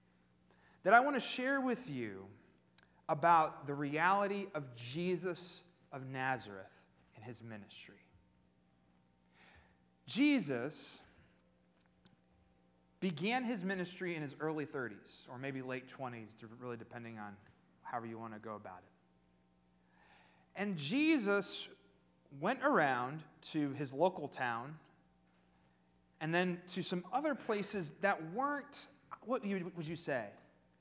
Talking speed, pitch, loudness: 115 wpm, 135 Hz, -37 LUFS